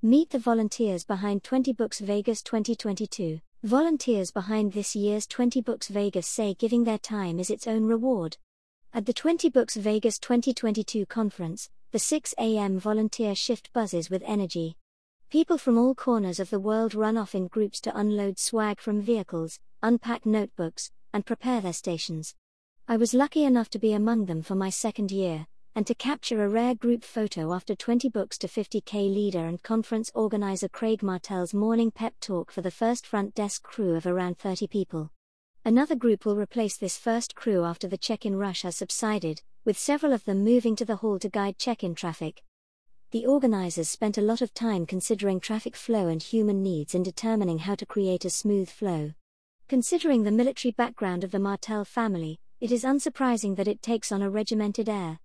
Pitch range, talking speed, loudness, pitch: 195-230 Hz, 180 wpm, -27 LUFS, 215 Hz